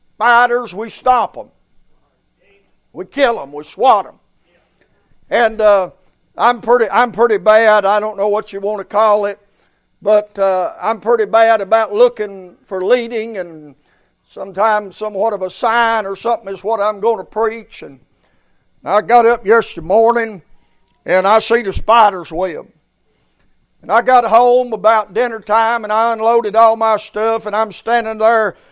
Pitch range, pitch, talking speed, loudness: 205-230 Hz, 220 Hz, 165 wpm, -14 LUFS